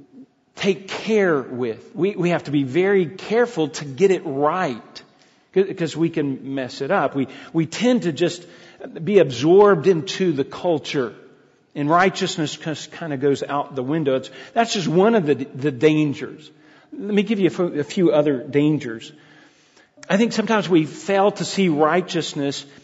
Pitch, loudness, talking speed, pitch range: 165 Hz, -20 LUFS, 165 wpm, 145-195 Hz